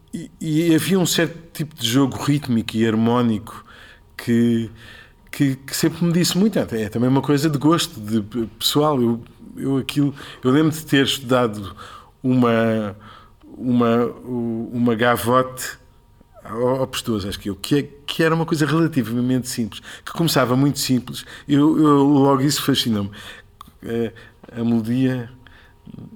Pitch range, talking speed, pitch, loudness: 115-145 Hz, 140 wpm, 125 Hz, -20 LUFS